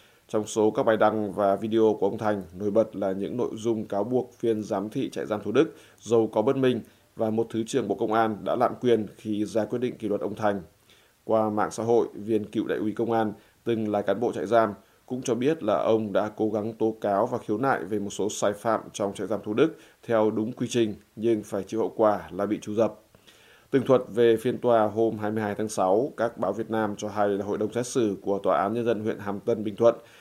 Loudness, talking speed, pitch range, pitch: -26 LUFS, 255 wpm, 105-115 Hz, 110 Hz